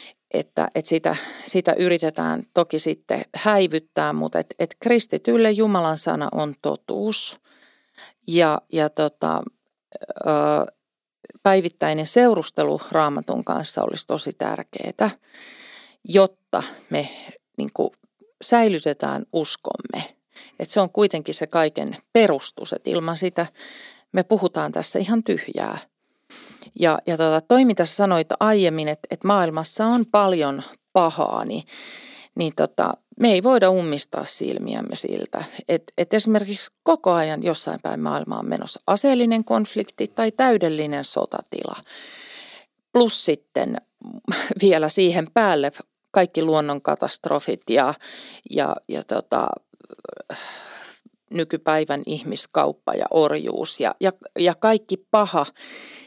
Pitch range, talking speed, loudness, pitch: 160-220 Hz, 110 wpm, -22 LUFS, 185 Hz